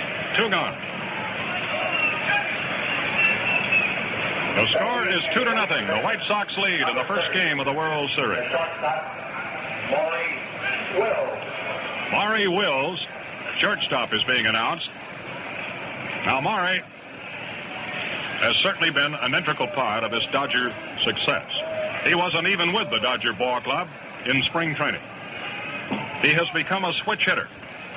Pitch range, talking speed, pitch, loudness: 140-195 Hz, 120 wpm, 165 Hz, -23 LUFS